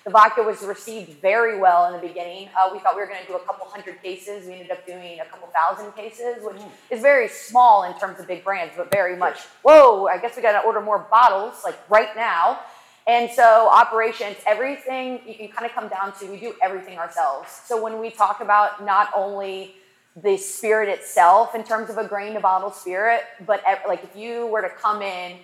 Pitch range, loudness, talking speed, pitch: 190-225 Hz, -19 LUFS, 225 wpm, 205 Hz